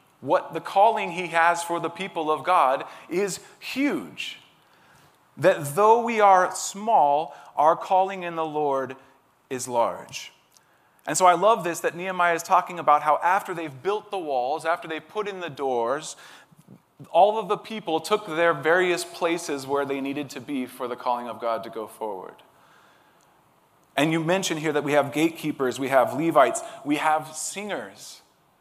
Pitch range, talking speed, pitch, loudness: 145-185 Hz, 170 wpm, 165 Hz, -24 LUFS